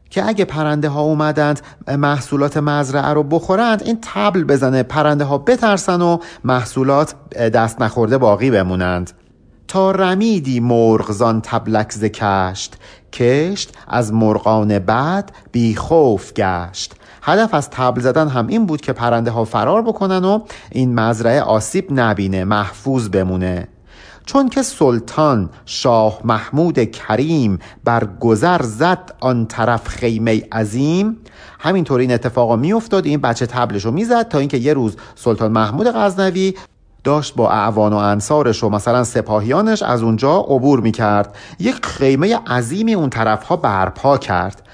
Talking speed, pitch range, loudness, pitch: 140 wpm, 110-155 Hz, -16 LUFS, 125 Hz